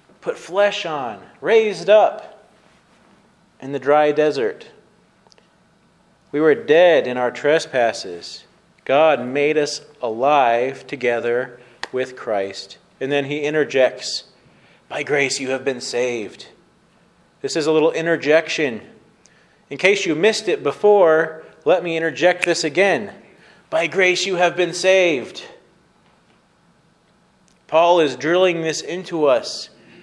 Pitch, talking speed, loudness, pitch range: 160 Hz, 120 wpm, -18 LUFS, 135-180 Hz